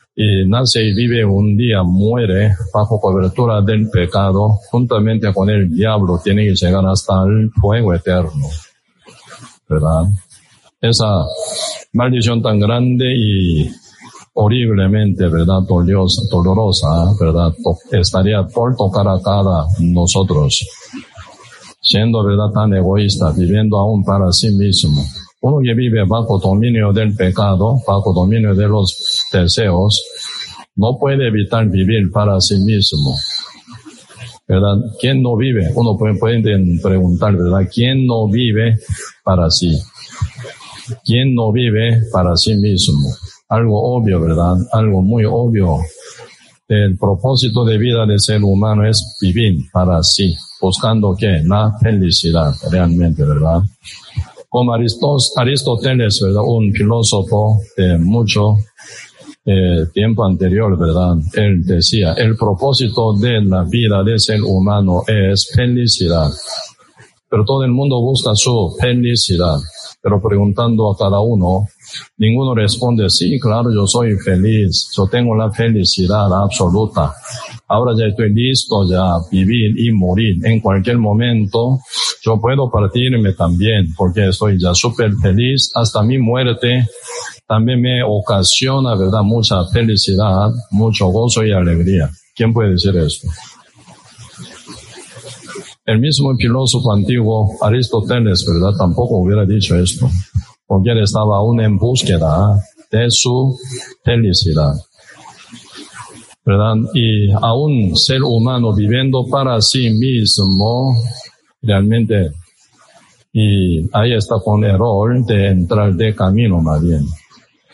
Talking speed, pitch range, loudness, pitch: 120 wpm, 95-115 Hz, -13 LUFS, 105 Hz